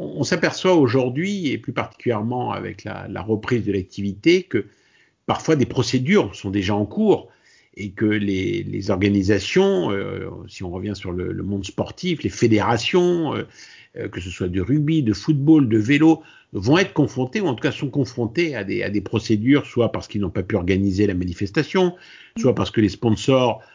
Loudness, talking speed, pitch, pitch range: -21 LUFS, 185 wpm, 115 Hz, 100-145 Hz